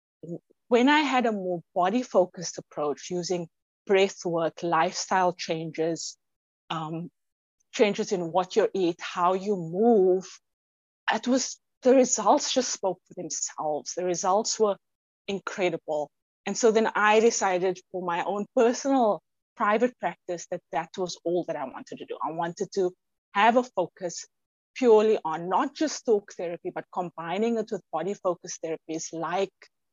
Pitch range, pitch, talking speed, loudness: 170-220 Hz, 185 Hz, 150 wpm, -26 LUFS